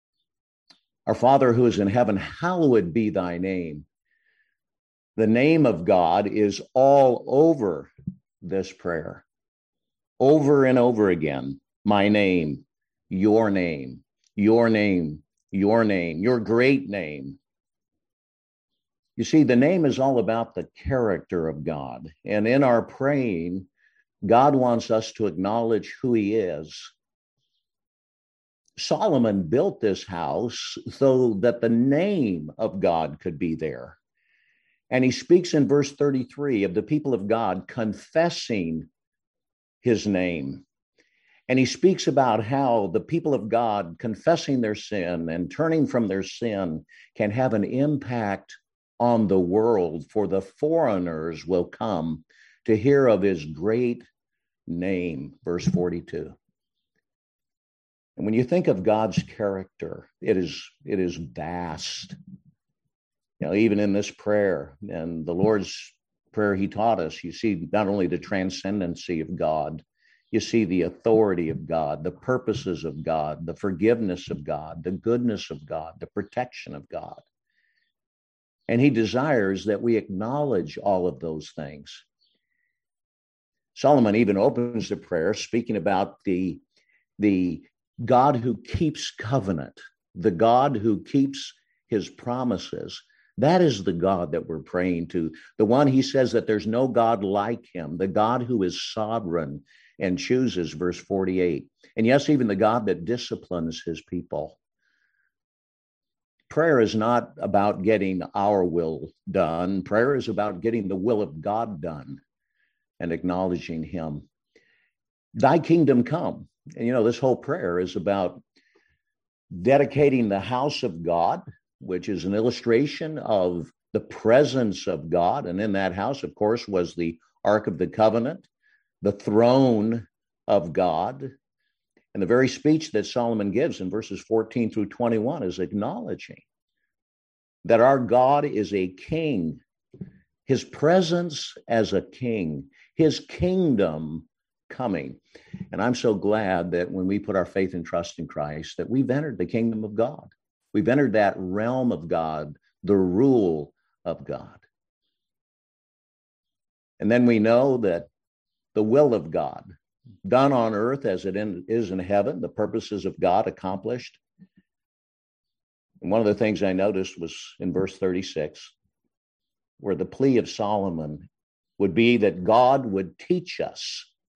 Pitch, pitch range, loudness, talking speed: 105 Hz, 90-125 Hz, -24 LUFS, 140 wpm